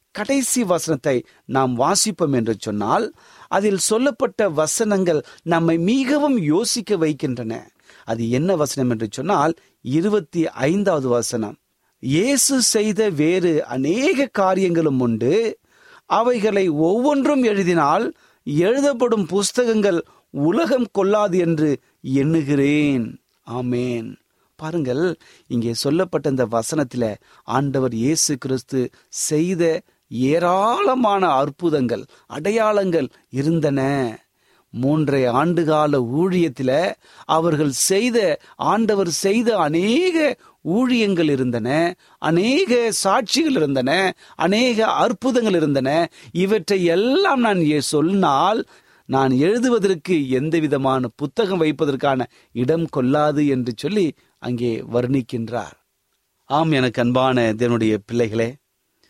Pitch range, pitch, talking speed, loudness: 130-205 Hz, 160 Hz, 90 wpm, -19 LUFS